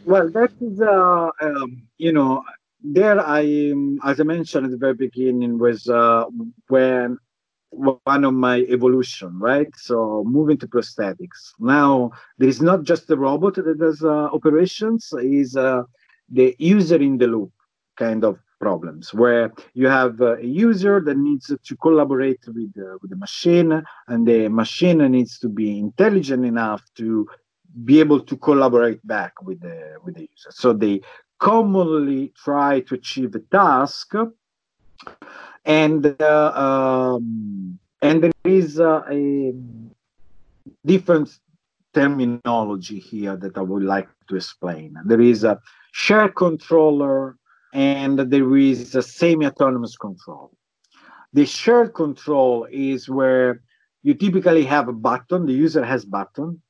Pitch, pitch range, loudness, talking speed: 135 Hz, 120-160 Hz, -18 LUFS, 140 wpm